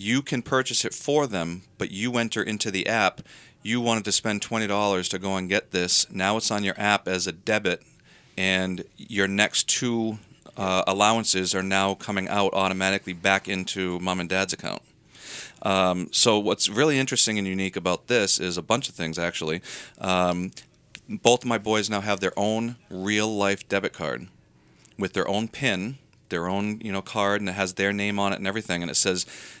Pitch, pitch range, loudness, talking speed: 100 Hz, 95-110 Hz, -24 LUFS, 195 wpm